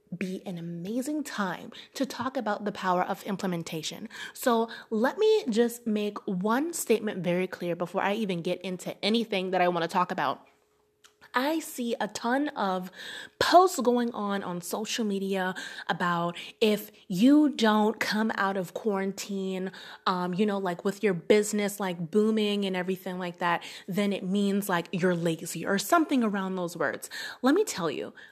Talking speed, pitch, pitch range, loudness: 165 wpm, 200 Hz, 185-235 Hz, -28 LUFS